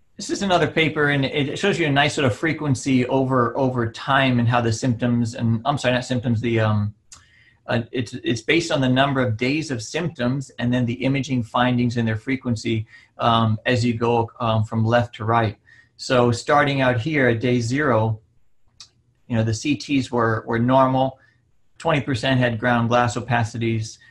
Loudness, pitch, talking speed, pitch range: -21 LUFS, 120 Hz, 185 wpm, 115-135 Hz